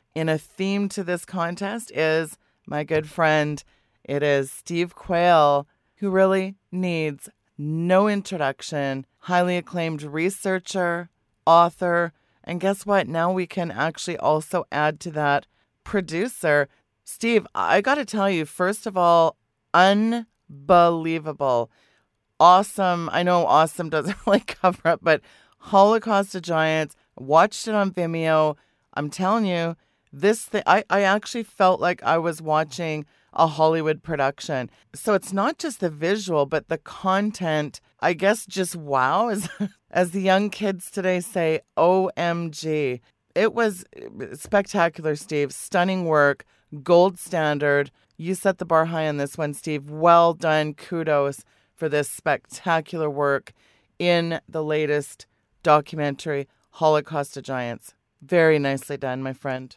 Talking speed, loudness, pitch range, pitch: 135 wpm, -22 LUFS, 150-185 Hz, 165 Hz